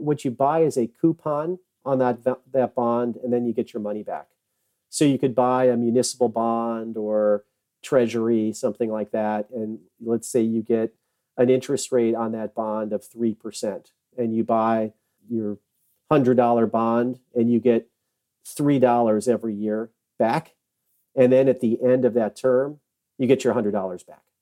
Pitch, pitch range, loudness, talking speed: 120 Hz, 110-125 Hz, -23 LUFS, 165 wpm